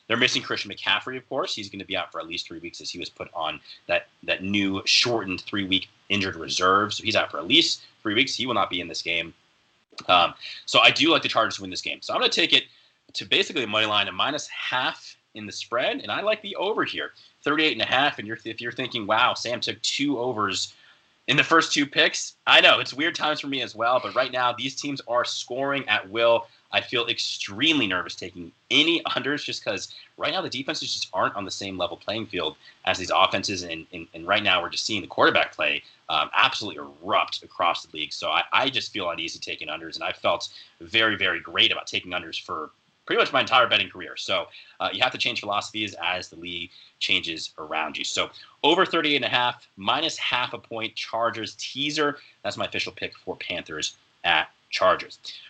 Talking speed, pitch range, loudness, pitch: 230 wpm, 100-145 Hz, -24 LUFS, 115 Hz